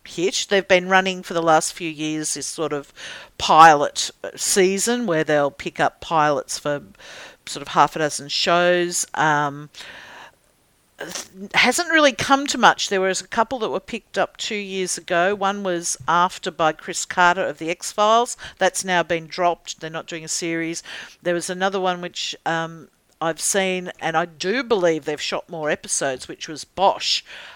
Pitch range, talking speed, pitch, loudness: 160-195 Hz, 175 wpm, 175 Hz, -20 LUFS